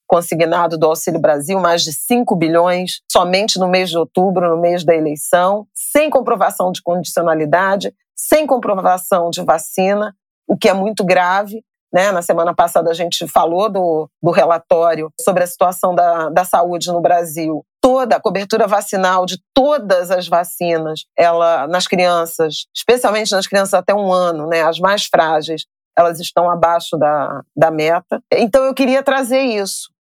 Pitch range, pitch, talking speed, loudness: 170-200 Hz, 180 Hz, 160 wpm, -15 LUFS